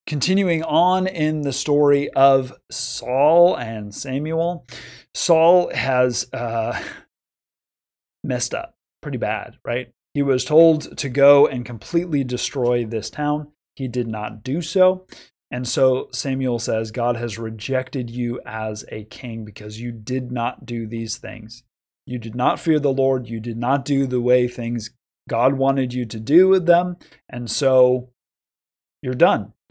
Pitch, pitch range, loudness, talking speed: 130 Hz, 120-145 Hz, -20 LUFS, 150 wpm